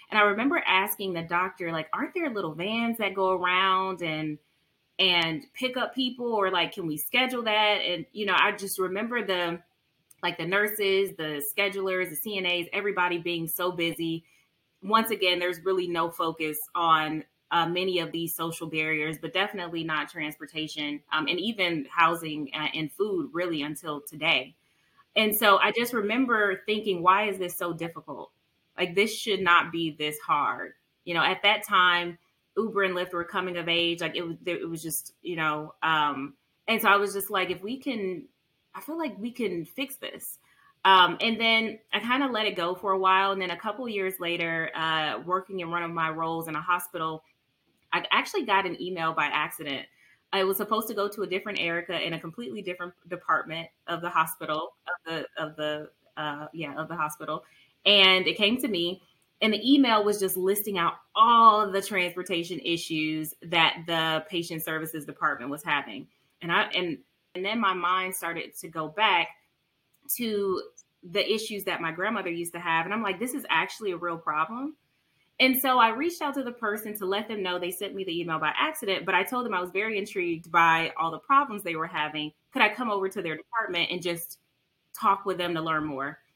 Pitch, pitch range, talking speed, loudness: 180 Hz, 165-205 Hz, 200 wpm, -27 LUFS